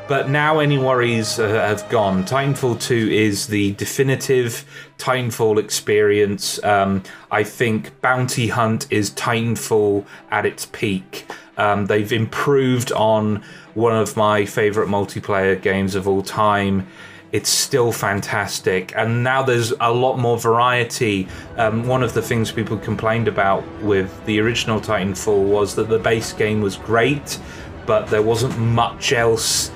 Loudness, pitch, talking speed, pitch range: -19 LUFS, 110 Hz, 145 wpm, 105-120 Hz